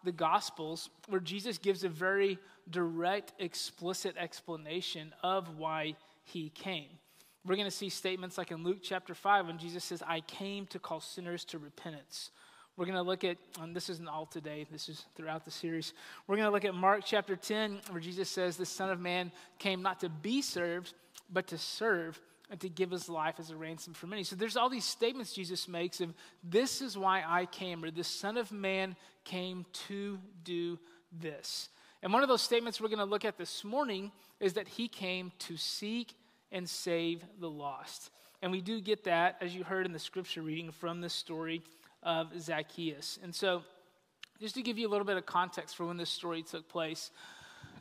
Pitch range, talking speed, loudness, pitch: 170-195 Hz, 205 wpm, -37 LUFS, 180 Hz